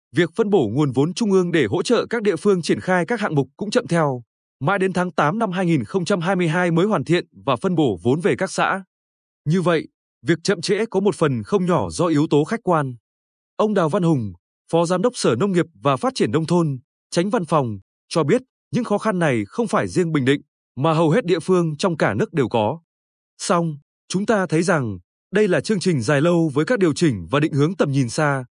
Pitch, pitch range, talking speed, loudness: 170 Hz, 145-195 Hz, 235 wpm, -20 LUFS